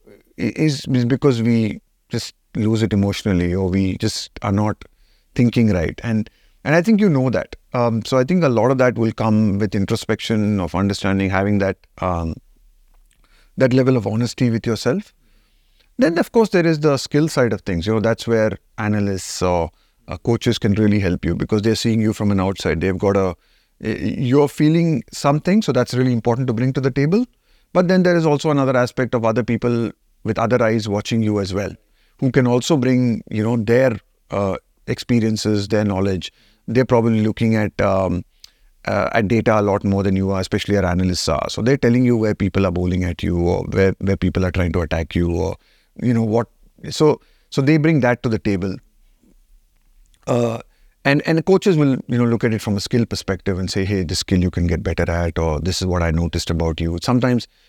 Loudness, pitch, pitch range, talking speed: -19 LUFS, 110 Hz, 95-125 Hz, 205 wpm